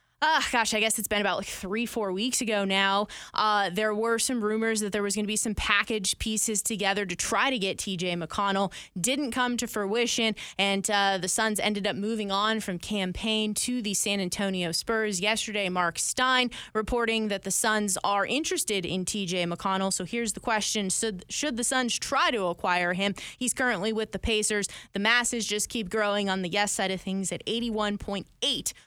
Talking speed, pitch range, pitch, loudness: 195 wpm, 195-225 Hz, 210 Hz, -27 LUFS